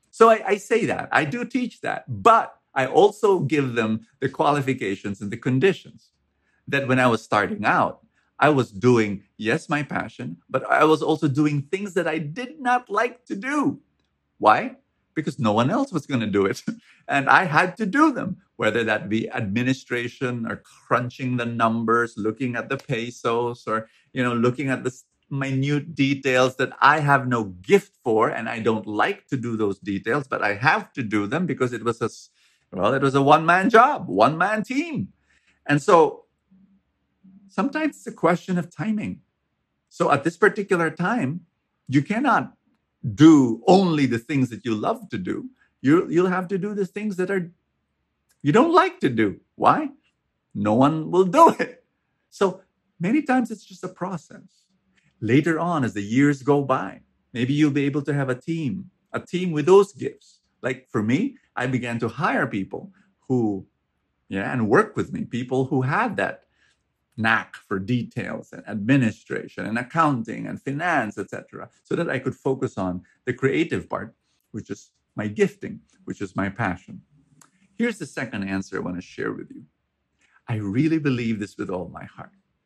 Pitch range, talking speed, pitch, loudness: 120-195 Hz, 180 wpm, 145 Hz, -22 LUFS